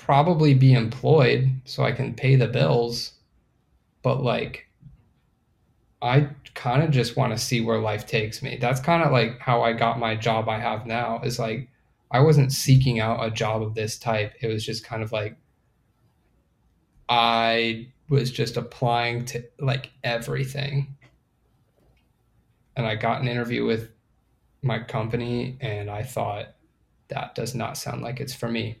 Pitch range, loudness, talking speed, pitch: 115-130 Hz, -24 LUFS, 160 wpm, 120 Hz